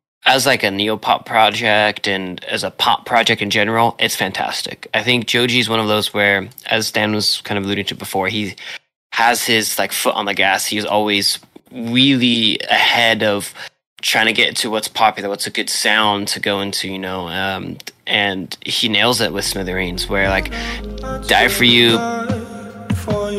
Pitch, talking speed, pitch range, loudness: 105 Hz, 175 wpm, 100-115 Hz, -16 LUFS